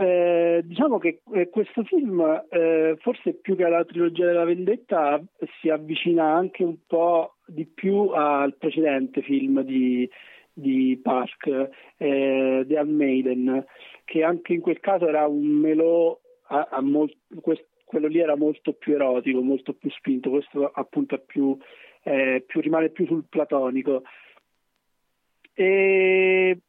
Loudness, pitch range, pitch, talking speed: -23 LUFS, 140-175 Hz, 160 Hz, 130 wpm